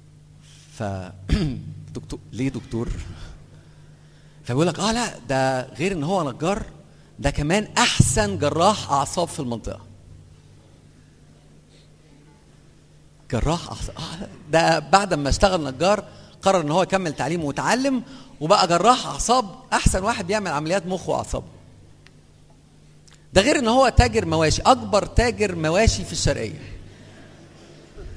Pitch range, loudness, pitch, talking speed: 130-195 Hz, -21 LUFS, 155 Hz, 115 wpm